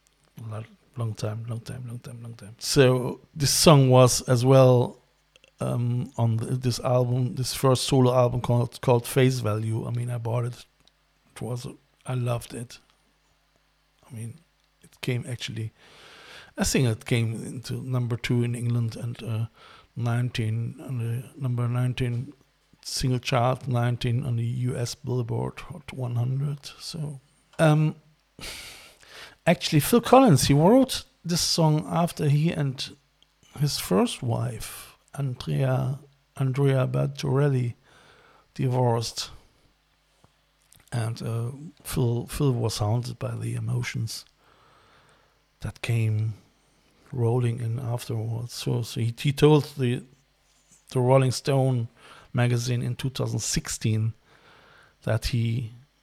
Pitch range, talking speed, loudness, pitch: 120-140 Hz, 125 wpm, -25 LUFS, 125 Hz